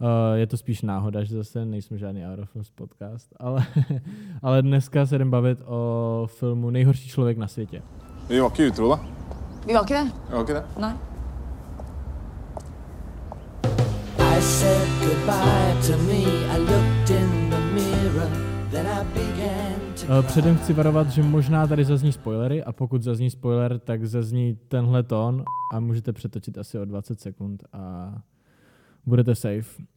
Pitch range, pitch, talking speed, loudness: 100-130 Hz, 115 Hz, 95 wpm, -23 LUFS